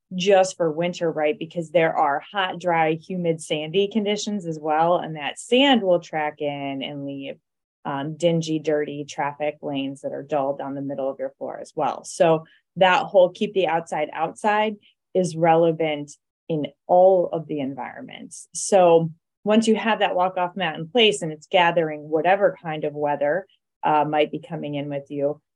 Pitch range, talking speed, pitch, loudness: 150-185 Hz, 180 wpm, 165 Hz, -22 LUFS